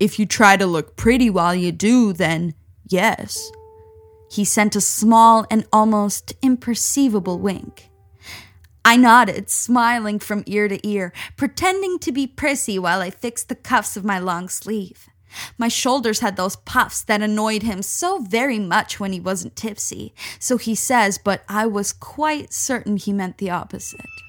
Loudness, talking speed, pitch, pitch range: -18 LUFS, 165 wpm, 210 Hz, 185-230 Hz